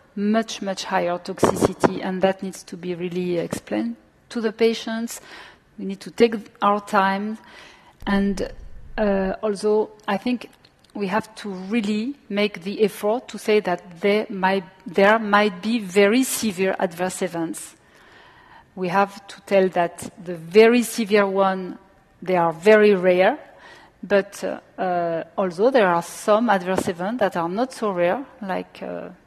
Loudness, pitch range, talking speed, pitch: -21 LUFS, 185-215 Hz, 150 wpm, 200 Hz